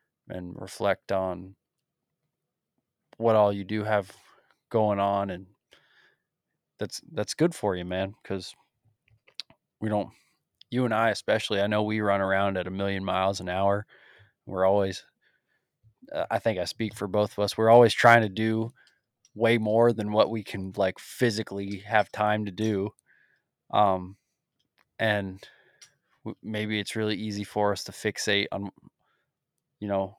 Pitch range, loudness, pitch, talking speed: 95-110 Hz, -26 LUFS, 105 Hz, 155 wpm